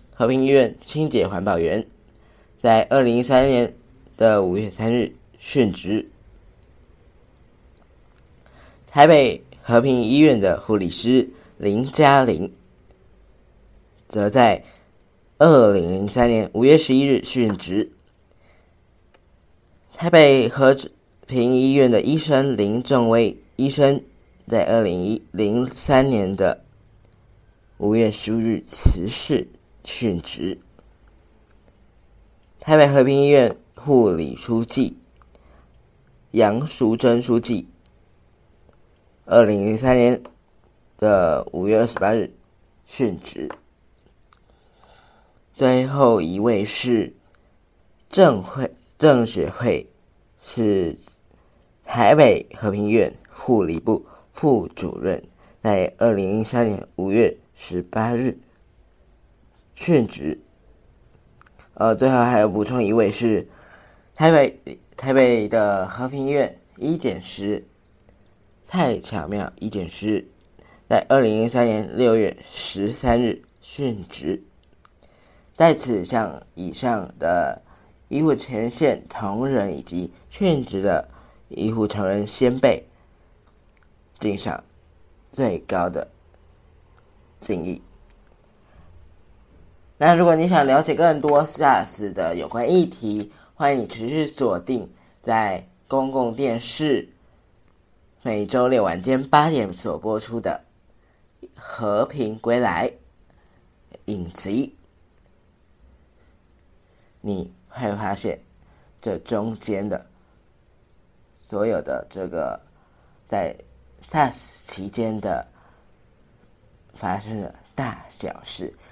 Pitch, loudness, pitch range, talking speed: 110 Hz, -20 LUFS, 95-130 Hz, 145 characters per minute